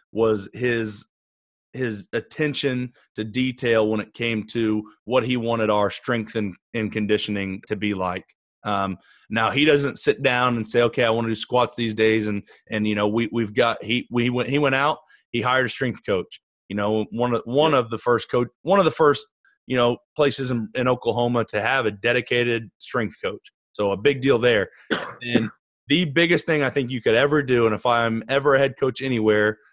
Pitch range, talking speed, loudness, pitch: 110-130 Hz, 210 wpm, -22 LUFS, 115 Hz